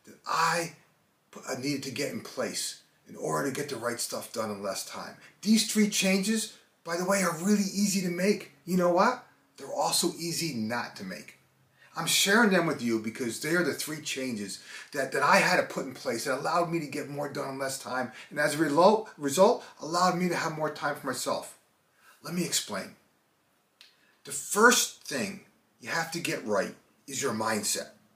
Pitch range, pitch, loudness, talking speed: 145-195 Hz, 165 Hz, -28 LUFS, 200 wpm